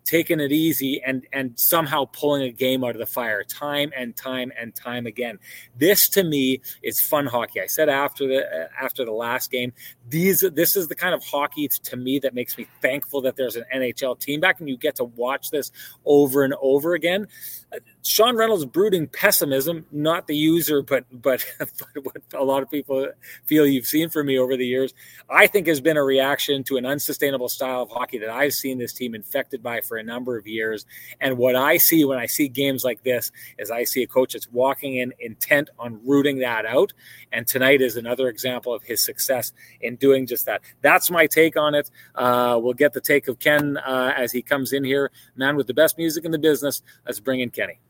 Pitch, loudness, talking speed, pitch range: 135 Hz, -21 LUFS, 215 wpm, 125-150 Hz